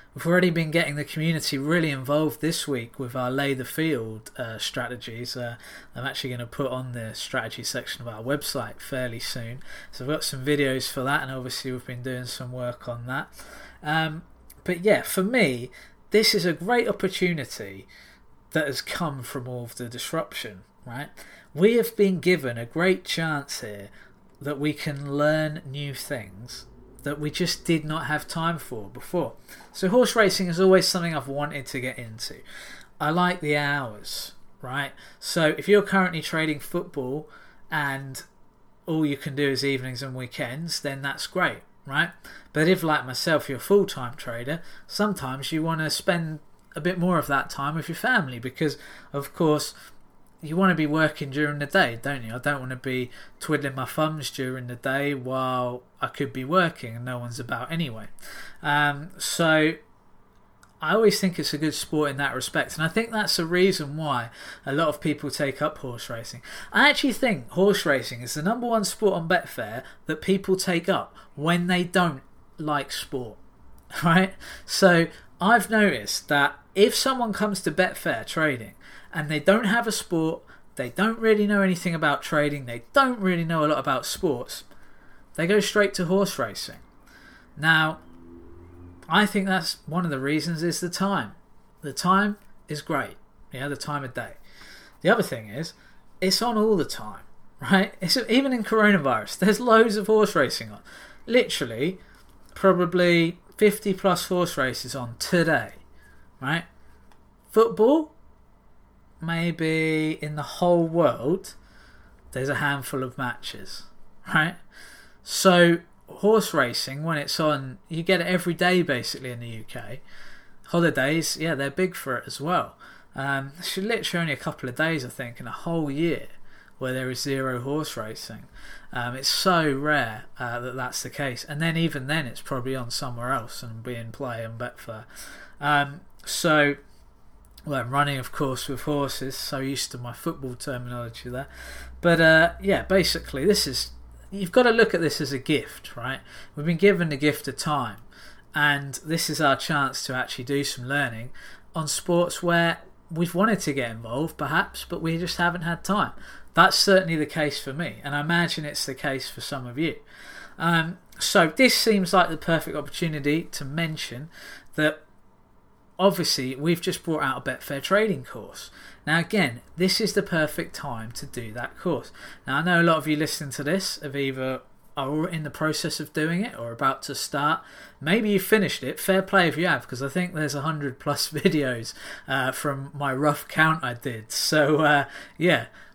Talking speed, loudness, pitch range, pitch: 180 wpm, -25 LUFS, 130-175 Hz, 150 Hz